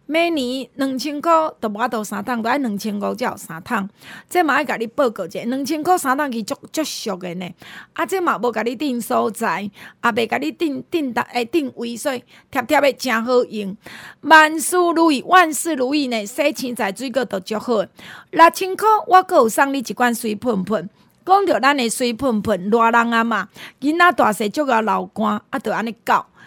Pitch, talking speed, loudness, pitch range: 250 Hz, 270 characters per minute, -19 LUFS, 225-305 Hz